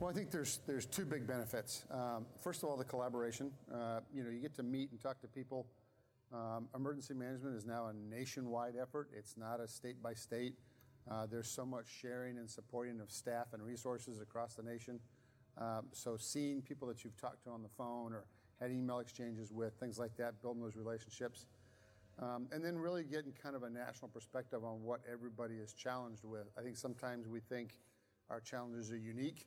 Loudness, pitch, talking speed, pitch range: -47 LUFS, 120 Hz, 200 wpm, 115-130 Hz